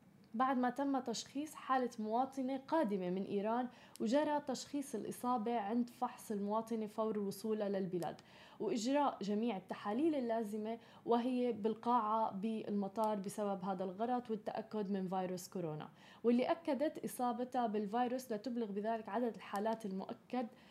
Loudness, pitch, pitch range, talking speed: -39 LUFS, 225 Hz, 205-250 Hz, 120 wpm